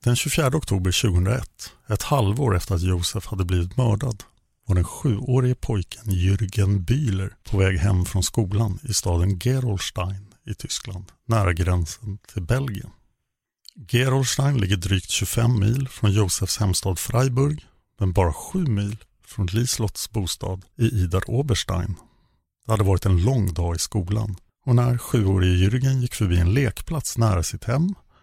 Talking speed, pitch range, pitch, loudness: 150 wpm, 95-120 Hz, 105 Hz, -23 LUFS